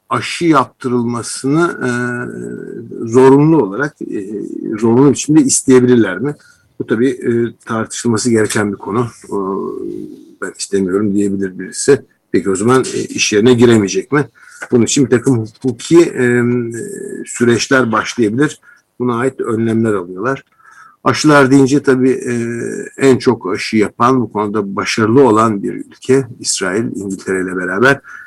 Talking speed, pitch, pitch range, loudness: 110 wpm, 120 Hz, 110-135 Hz, -14 LUFS